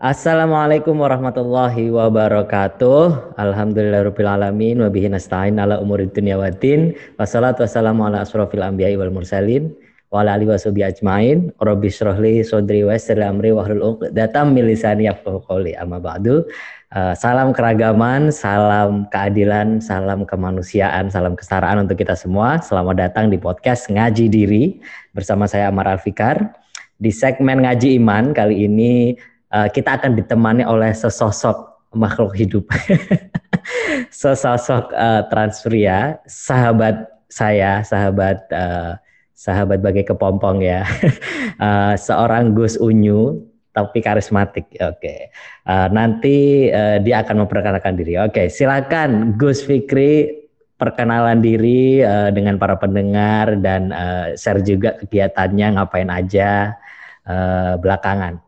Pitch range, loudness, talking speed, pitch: 100-120 Hz, -16 LUFS, 110 wpm, 105 Hz